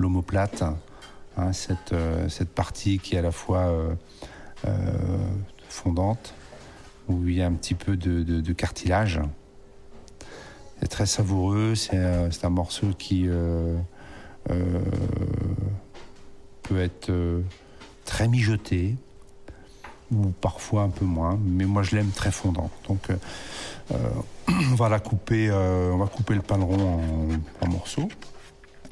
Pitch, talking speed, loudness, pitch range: 95 Hz, 140 wpm, -26 LUFS, 90-100 Hz